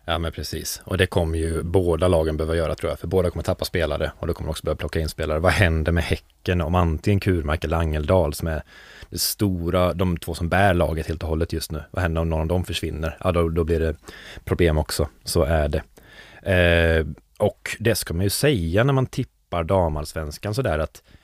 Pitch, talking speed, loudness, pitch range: 85 Hz, 225 wpm, -23 LUFS, 80-90 Hz